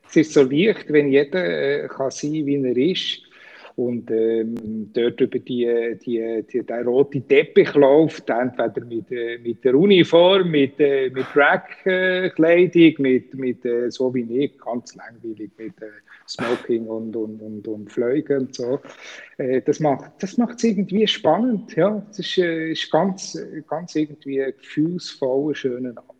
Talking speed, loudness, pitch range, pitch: 155 wpm, -20 LUFS, 120-170 Hz, 140 Hz